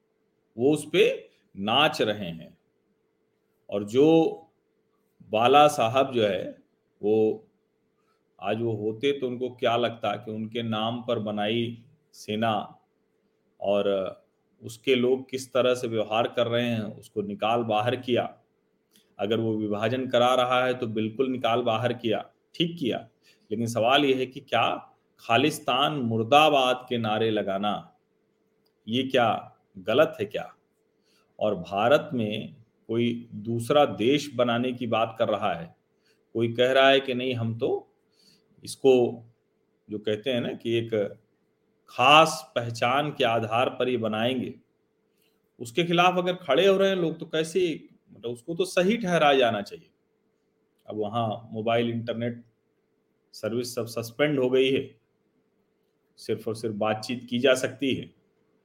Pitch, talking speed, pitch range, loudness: 120 Hz, 140 wpm, 110-135 Hz, -25 LUFS